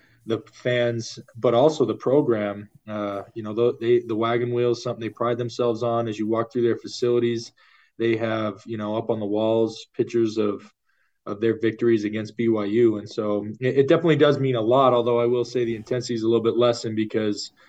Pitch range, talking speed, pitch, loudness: 110-120 Hz, 210 wpm, 115 Hz, -23 LUFS